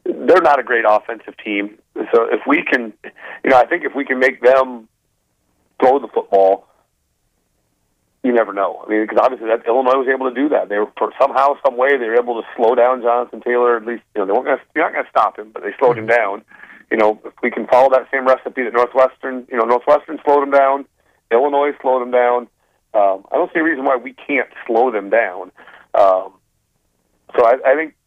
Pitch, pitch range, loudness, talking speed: 120 Hz, 105-135 Hz, -16 LUFS, 225 wpm